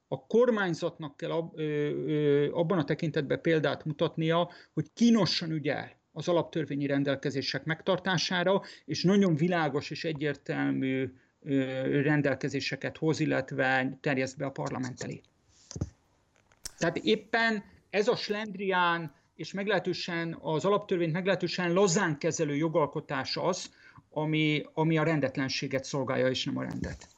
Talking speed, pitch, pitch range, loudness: 110 wpm, 155 Hz, 140-175 Hz, -30 LUFS